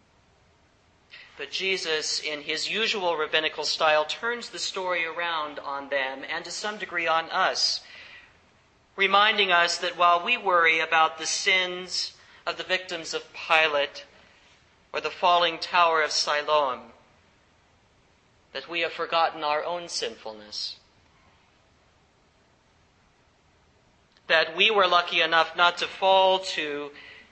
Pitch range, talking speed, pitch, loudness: 140-175 Hz, 120 wpm, 160 Hz, -24 LUFS